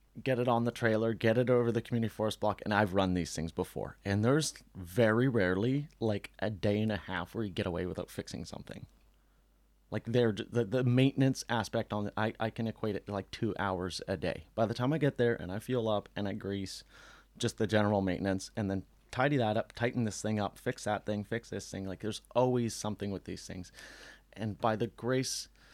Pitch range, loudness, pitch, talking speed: 100-120 Hz, -33 LUFS, 110 Hz, 225 wpm